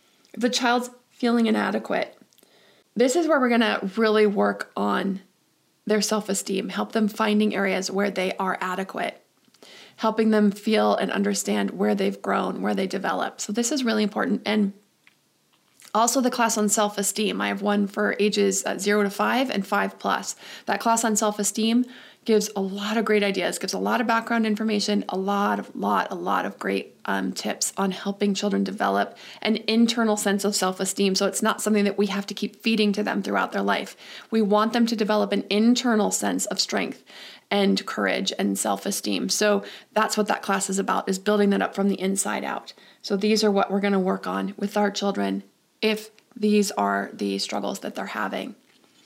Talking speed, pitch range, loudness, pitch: 190 wpm, 195-220 Hz, -24 LUFS, 205 Hz